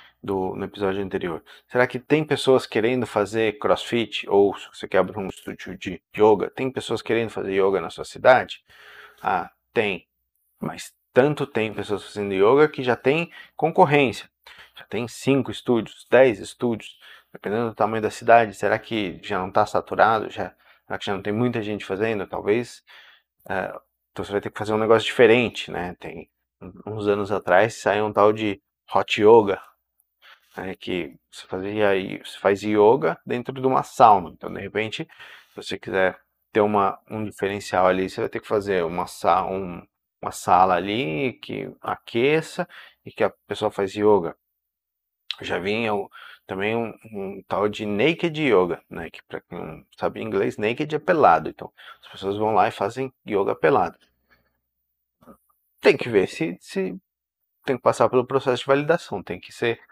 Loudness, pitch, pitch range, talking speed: -22 LUFS, 105 Hz, 95-120 Hz, 170 wpm